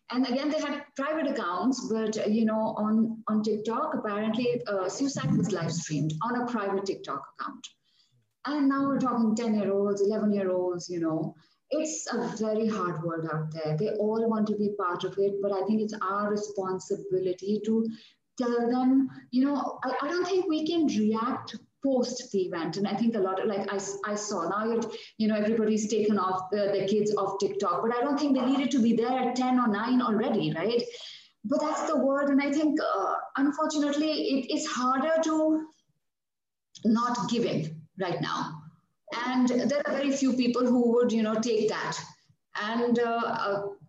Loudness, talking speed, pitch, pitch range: -28 LUFS, 185 wpm, 225 Hz, 200-260 Hz